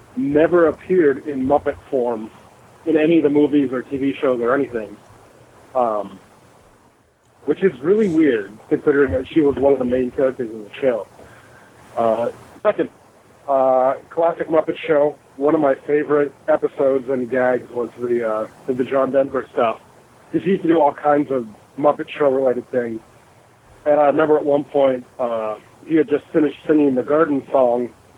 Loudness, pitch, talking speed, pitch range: -19 LUFS, 140 Hz, 170 wpm, 125-150 Hz